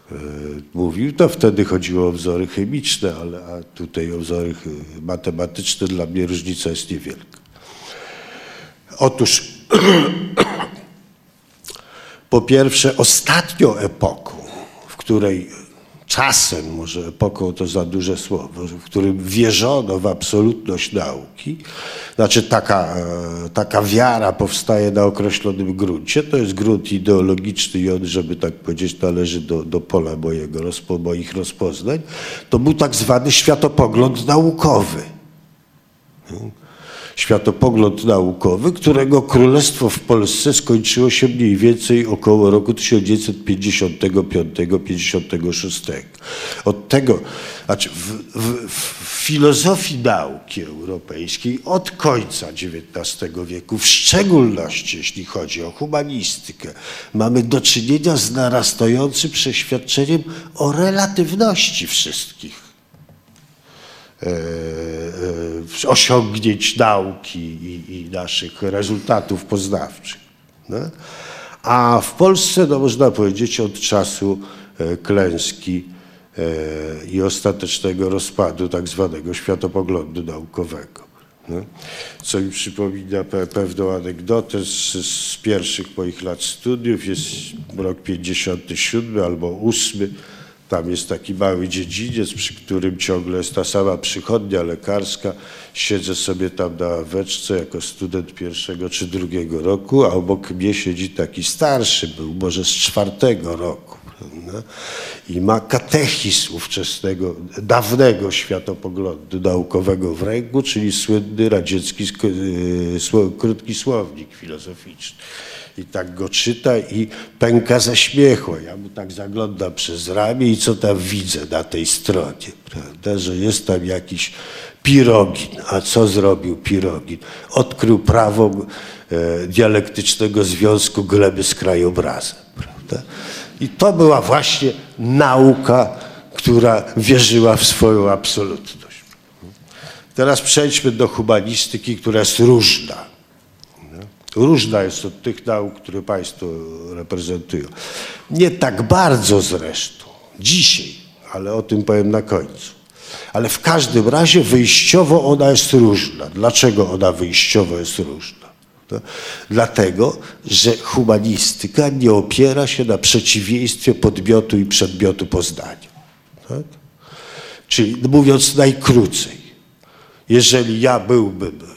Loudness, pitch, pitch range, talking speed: -16 LUFS, 100 Hz, 90-120 Hz, 110 wpm